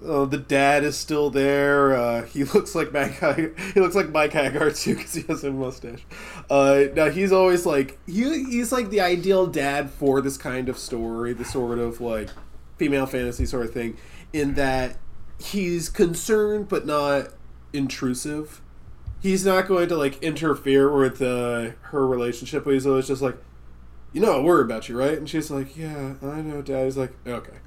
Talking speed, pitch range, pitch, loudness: 185 wpm, 130-160 Hz, 140 Hz, -23 LUFS